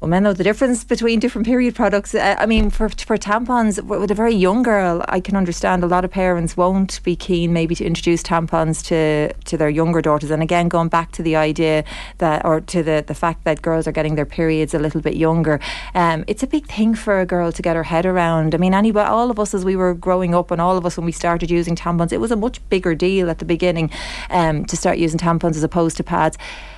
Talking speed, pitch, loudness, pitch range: 255 wpm, 175 Hz, -18 LUFS, 165-200 Hz